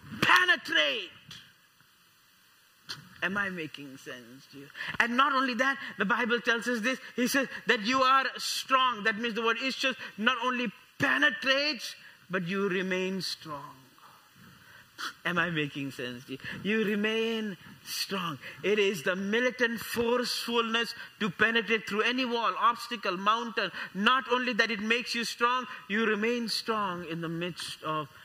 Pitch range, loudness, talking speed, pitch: 190-245 Hz, -28 LUFS, 150 wpm, 225 Hz